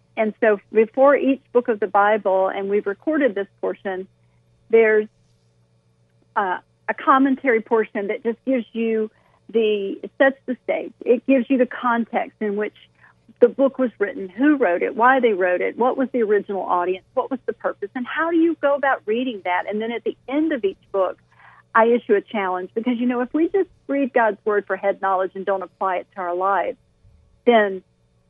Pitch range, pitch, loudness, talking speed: 195-255 Hz, 225 Hz, -21 LUFS, 200 wpm